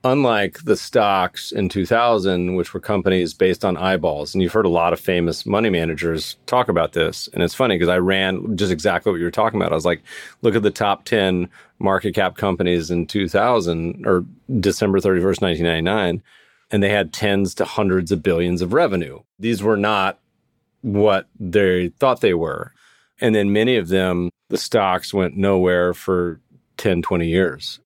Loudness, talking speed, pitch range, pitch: -19 LUFS, 180 wpm, 90-100 Hz, 95 Hz